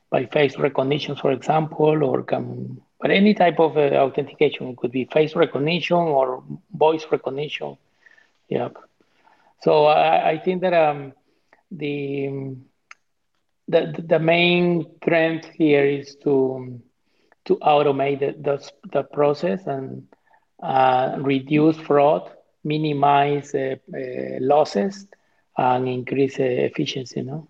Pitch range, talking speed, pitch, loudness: 135-155 Hz, 125 wpm, 145 Hz, -21 LUFS